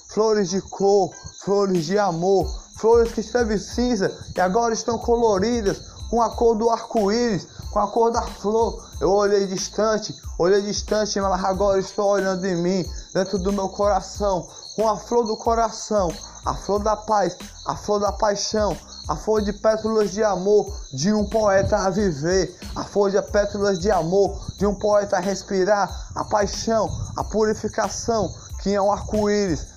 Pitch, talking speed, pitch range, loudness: 205 Hz, 165 wpm, 195-220 Hz, -22 LUFS